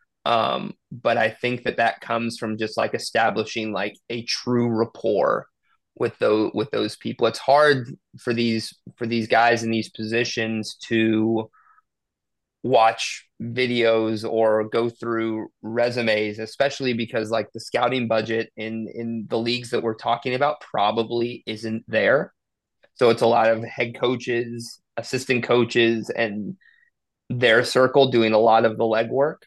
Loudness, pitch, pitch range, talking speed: -22 LUFS, 115 Hz, 110-120 Hz, 145 wpm